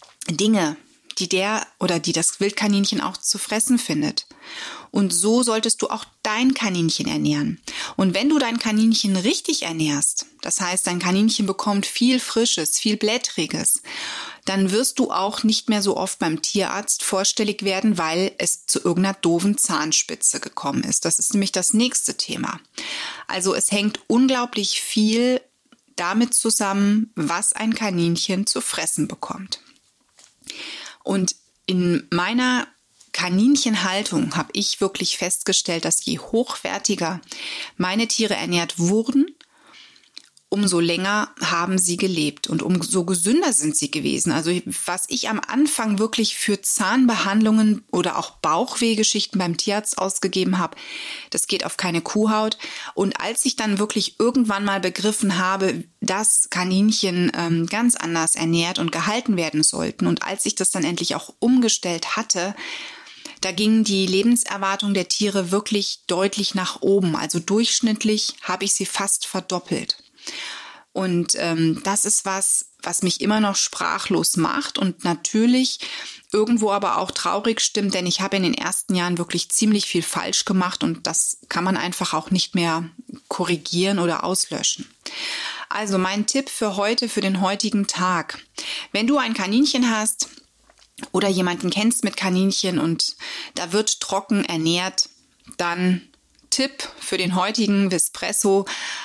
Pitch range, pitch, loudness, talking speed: 180-225 Hz, 200 Hz, -20 LUFS, 145 wpm